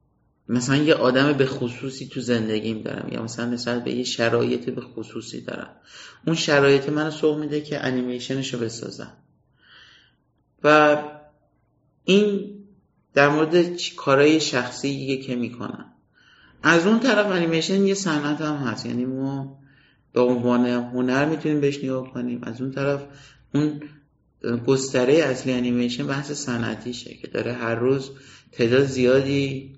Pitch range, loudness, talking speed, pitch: 125-150 Hz, -22 LUFS, 135 wpm, 135 Hz